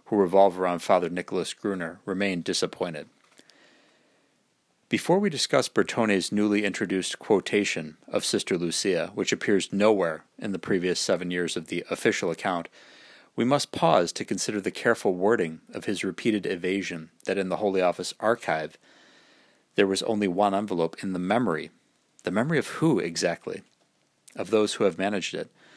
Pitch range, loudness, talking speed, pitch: 90-105 Hz, -26 LUFS, 155 wpm, 95 Hz